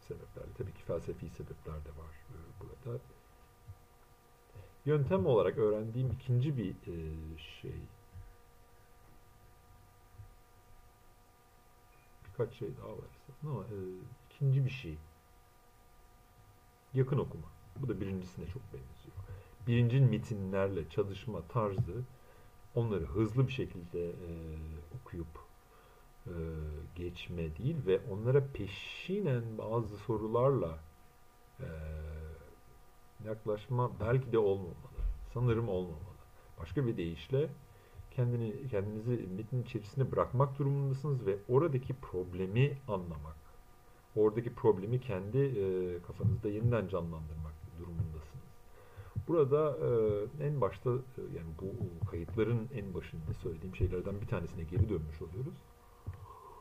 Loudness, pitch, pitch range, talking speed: -36 LUFS, 100 Hz, 85-125 Hz, 90 wpm